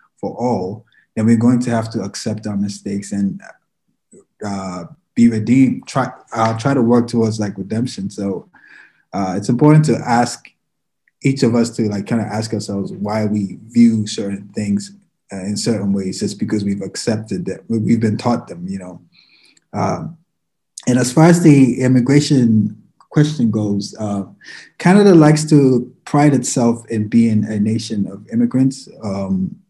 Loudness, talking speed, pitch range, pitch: -16 LUFS, 160 wpm, 105-130 Hz, 115 Hz